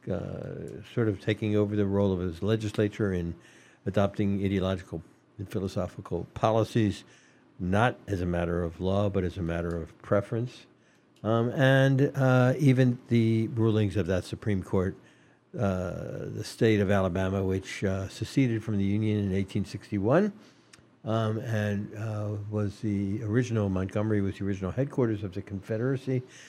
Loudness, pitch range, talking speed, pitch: -28 LUFS, 95-115 Hz, 145 wpm, 105 Hz